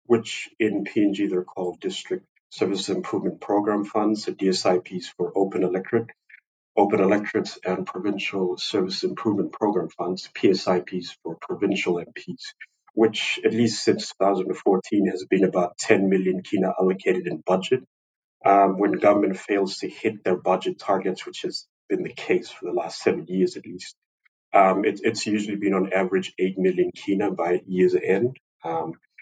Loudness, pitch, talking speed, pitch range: -24 LUFS, 95 Hz, 160 wpm, 90-105 Hz